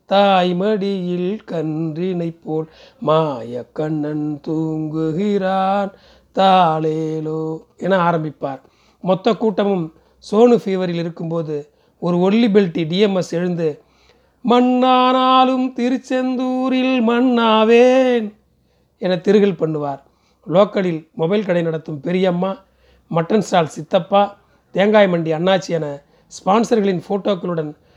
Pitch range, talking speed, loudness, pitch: 160-210 Hz, 85 wpm, -17 LUFS, 185 Hz